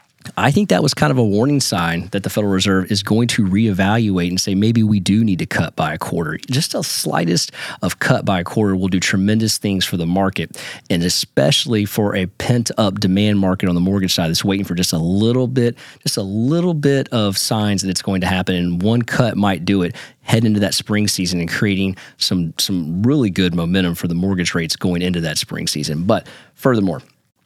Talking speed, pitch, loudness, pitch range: 220 wpm, 100 Hz, -17 LUFS, 90-110 Hz